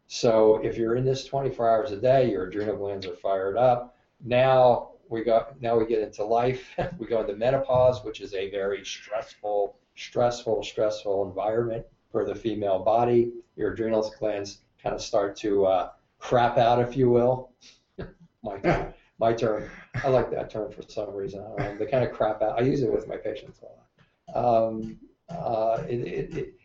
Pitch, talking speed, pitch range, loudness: 115 Hz, 180 wpm, 105-130 Hz, -26 LUFS